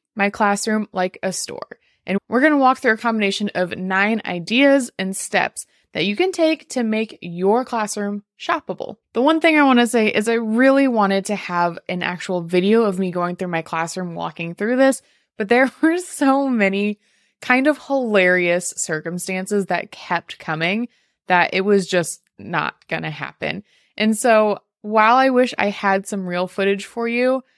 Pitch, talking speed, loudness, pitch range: 205 Hz, 175 wpm, -19 LUFS, 185-245 Hz